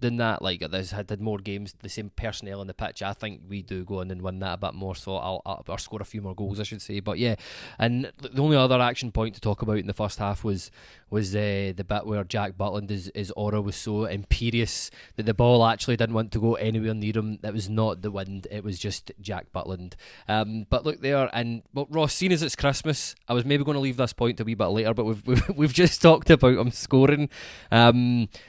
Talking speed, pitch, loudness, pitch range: 250 wpm, 110 Hz, -25 LUFS, 100-120 Hz